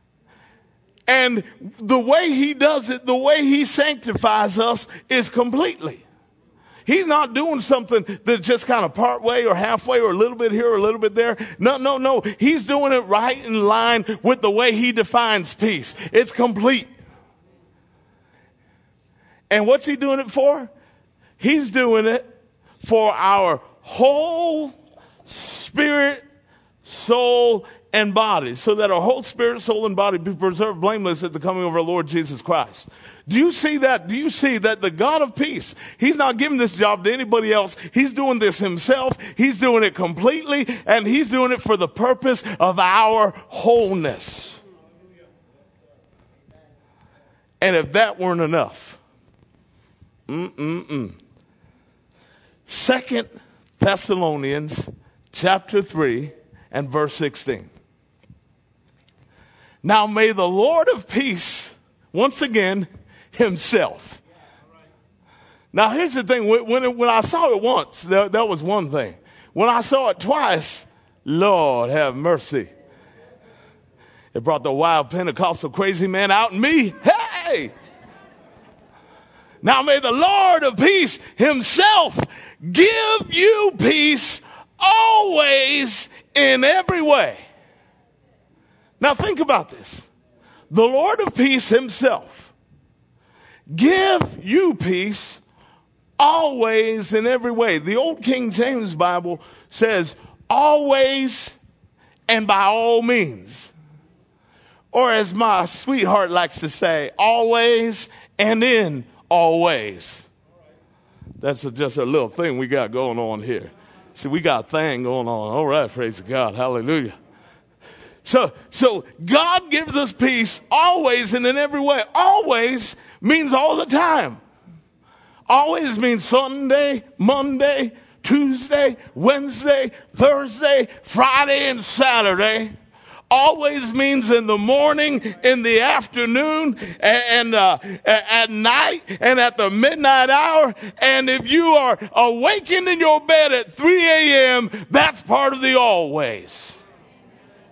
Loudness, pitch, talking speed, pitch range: -18 LUFS, 235 Hz, 130 wpm, 200-275 Hz